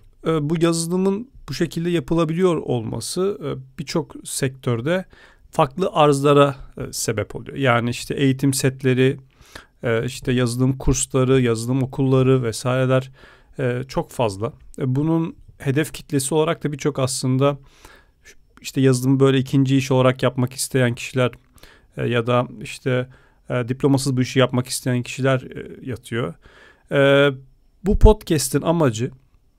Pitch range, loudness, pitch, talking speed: 125-150 Hz, -20 LUFS, 135 Hz, 105 wpm